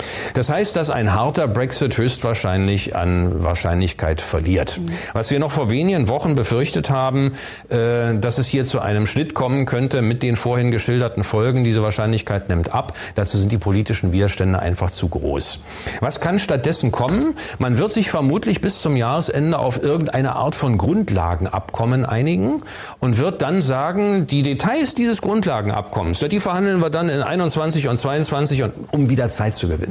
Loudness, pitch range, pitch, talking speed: -19 LUFS, 105-150 Hz, 125 Hz, 170 wpm